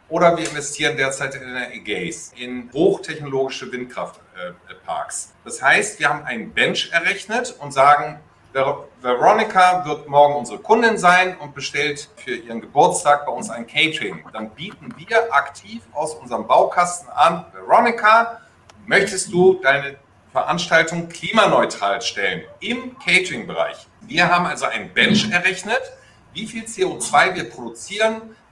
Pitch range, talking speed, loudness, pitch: 135-200 Hz, 135 wpm, -18 LUFS, 160 Hz